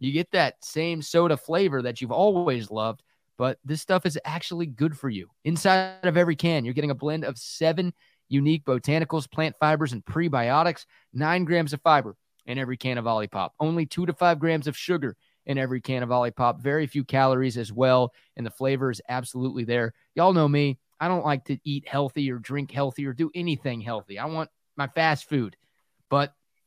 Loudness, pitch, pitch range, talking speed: -25 LUFS, 140 Hz, 130-160 Hz, 200 wpm